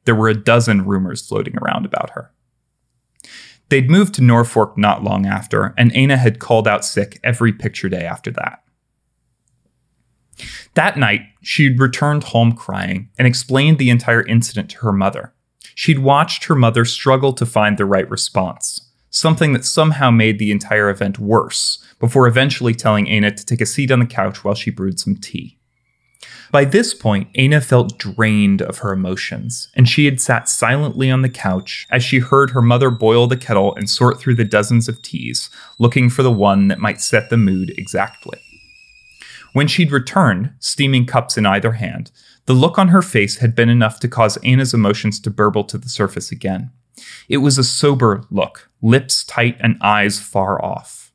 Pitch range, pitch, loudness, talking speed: 105-130 Hz, 120 Hz, -15 LUFS, 180 wpm